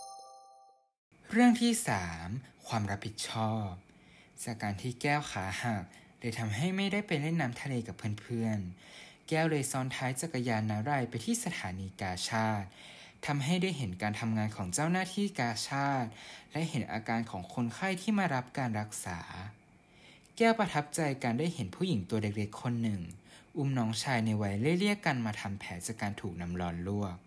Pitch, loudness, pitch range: 120 Hz, -33 LUFS, 105-150 Hz